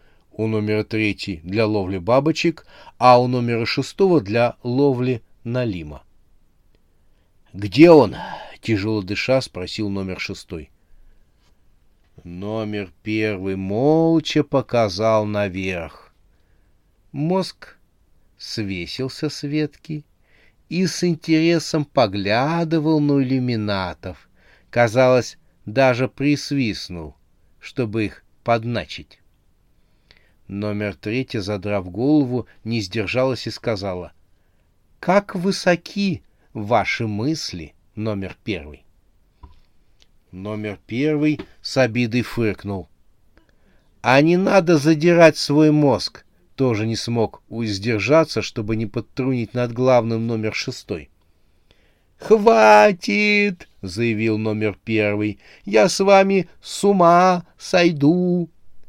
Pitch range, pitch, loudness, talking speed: 95-140 Hz, 110 Hz, -19 LUFS, 90 wpm